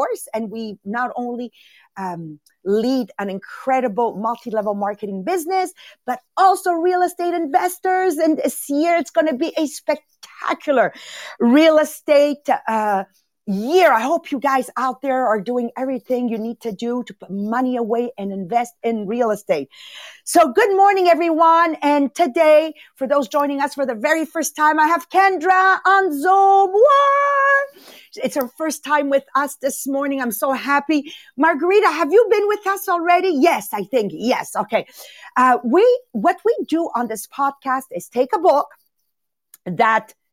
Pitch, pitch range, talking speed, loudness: 285 Hz, 240-335 Hz, 160 wpm, -18 LUFS